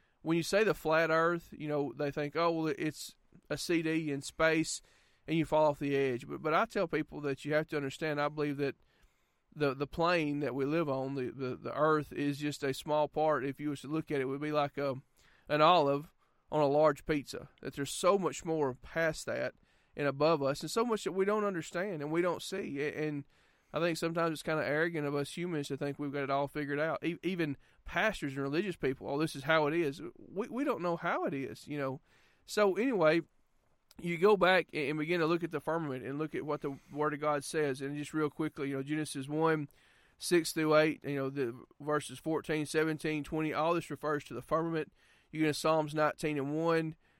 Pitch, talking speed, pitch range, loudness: 150 Hz, 230 wpm, 145-160 Hz, -33 LUFS